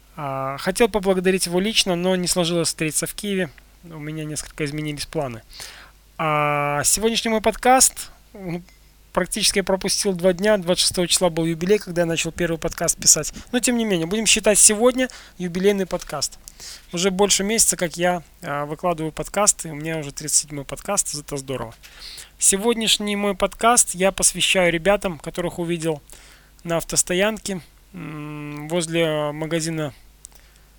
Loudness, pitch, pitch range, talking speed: -20 LUFS, 175 Hz, 155-200 Hz, 140 wpm